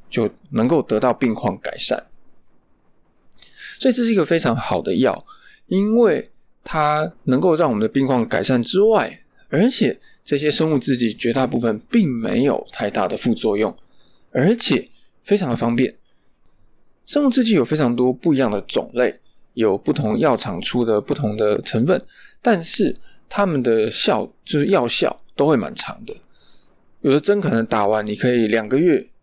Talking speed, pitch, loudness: 240 characters per minute, 135 Hz, -19 LUFS